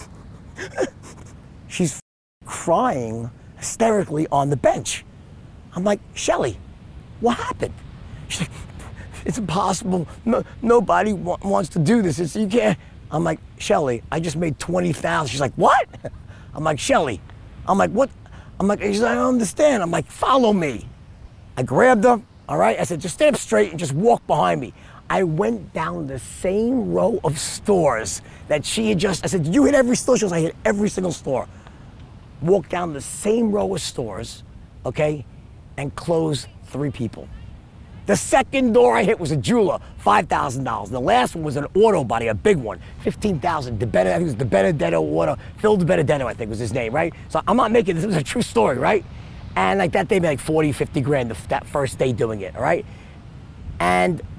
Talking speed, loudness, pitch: 190 wpm, -20 LUFS, 165 Hz